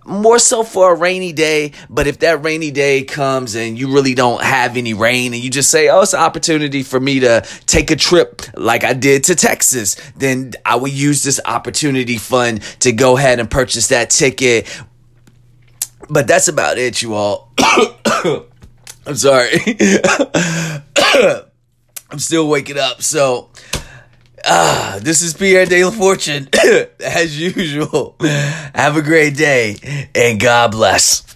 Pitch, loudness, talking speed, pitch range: 140 Hz, -13 LUFS, 155 wpm, 125-160 Hz